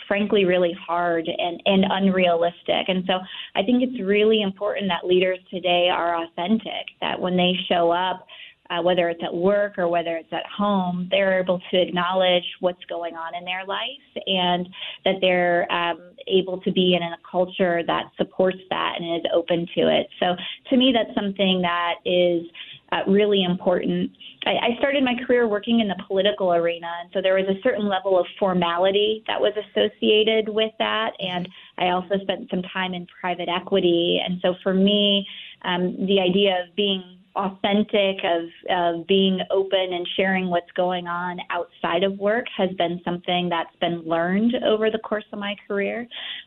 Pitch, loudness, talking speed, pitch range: 185 Hz, -22 LUFS, 180 wpm, 175-200 Hz